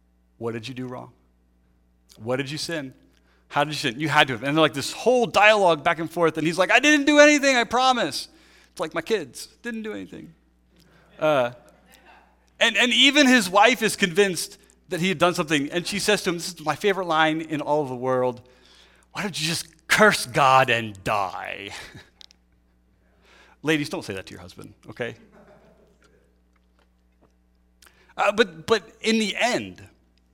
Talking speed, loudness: 180 wpm, -21 LUFS